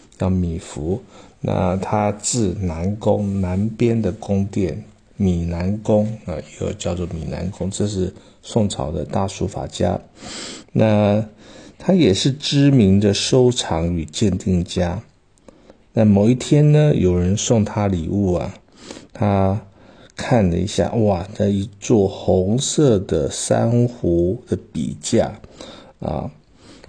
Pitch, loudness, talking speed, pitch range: 100 Hz, -19 LUFS, 165 characters per minute, 90-110 Hz